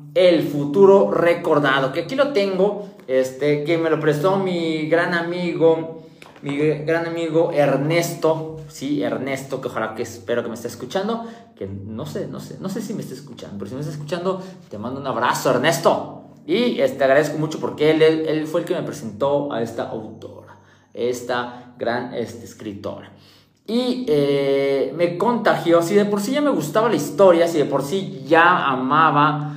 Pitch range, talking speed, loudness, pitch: 135-175 Hz, 180 wpm, -20 LUFS, 155 Hz